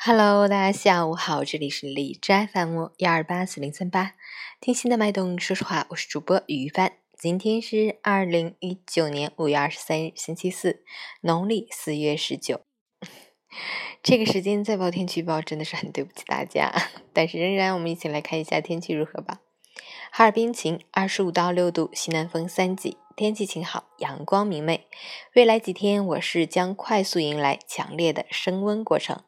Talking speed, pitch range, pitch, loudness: 260 characters per minute, 160-200 Hz, 180 Hz, -24 LUFS